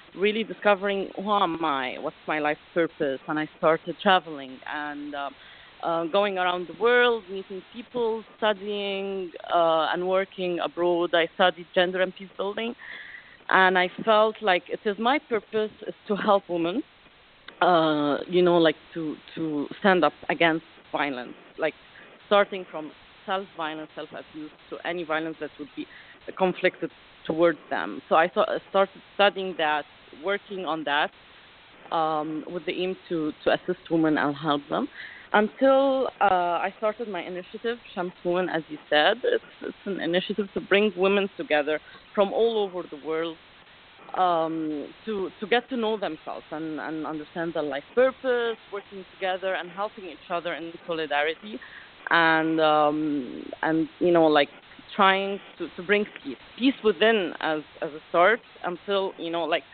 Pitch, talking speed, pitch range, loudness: 180 Hz, 155 wpm, 160-200 Hz, -25 LUFS